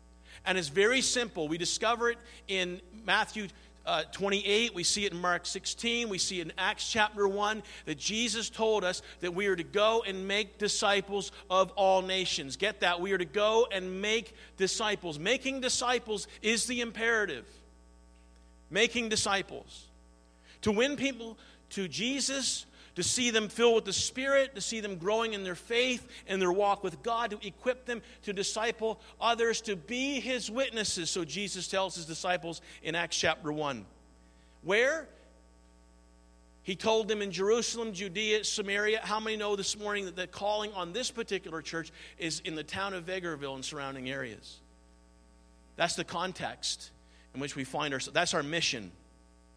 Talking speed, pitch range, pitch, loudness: 165 wpm, 160-220 Hz, 195 Hz, -31 LUFS